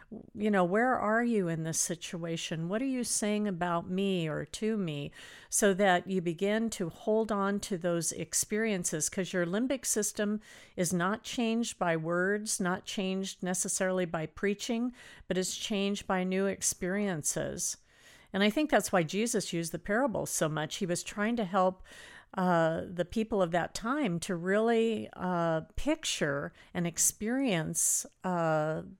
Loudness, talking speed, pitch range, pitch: -31 LUFS, 155 wpm, 175-215 Hz, 195 Hz